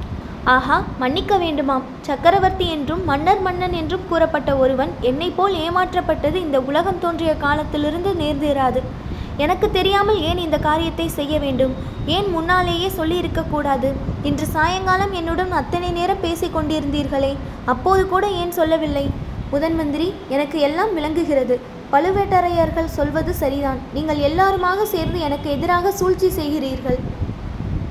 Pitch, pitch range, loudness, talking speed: 320 Hz, 285-365 Hz, -19 LUFS, 110 wpm